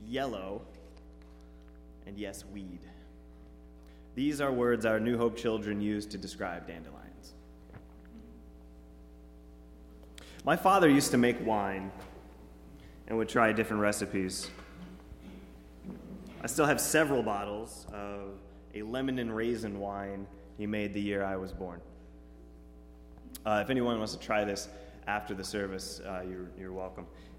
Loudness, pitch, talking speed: -32 LUFS, 95 Hz, 125 wpm